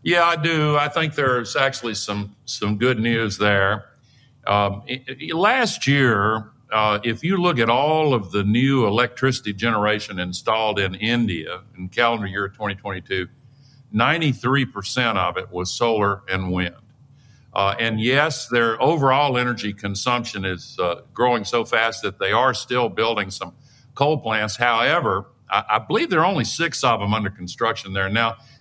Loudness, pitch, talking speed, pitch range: -21 LUFS, 115 Hz, 155 wpm, 100-130 Hz